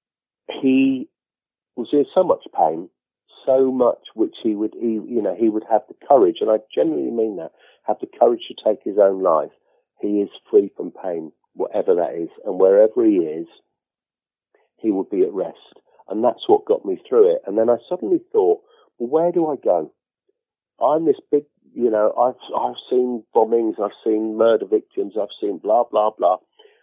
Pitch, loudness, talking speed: 335 Hz, -20 LUFS, 190 wpm